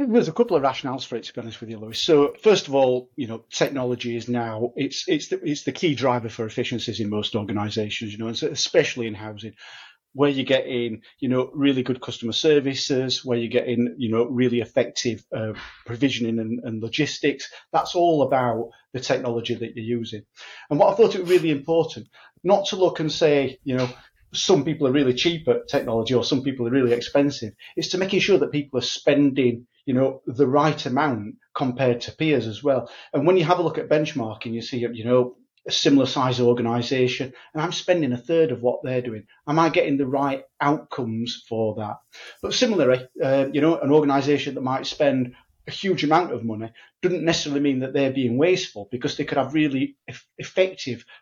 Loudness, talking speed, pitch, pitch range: -23 LUFS, 205 wpm, 130 Hz, 120-145 Hz